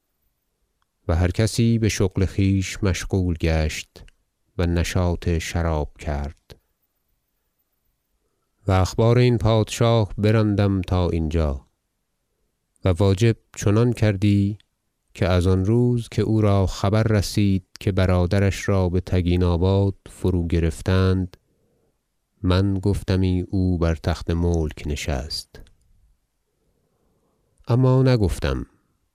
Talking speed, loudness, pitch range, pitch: 105 wpm, -21 LUFS, 85-105 Hz, 95 Hz